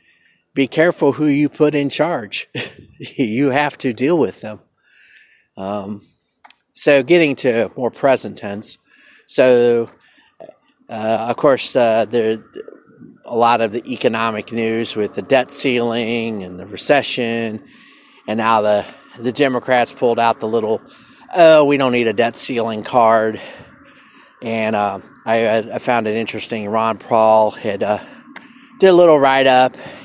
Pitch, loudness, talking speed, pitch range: 120 Hz, -16 LUFS, 145 wpm, 110-140 Hz